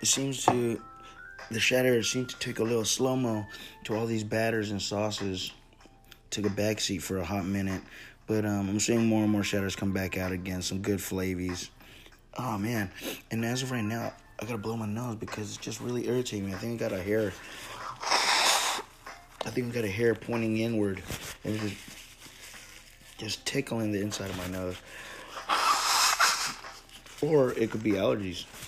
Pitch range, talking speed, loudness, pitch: 100-115 Hz, 180 wpm, -29 LUFS, 110 Hz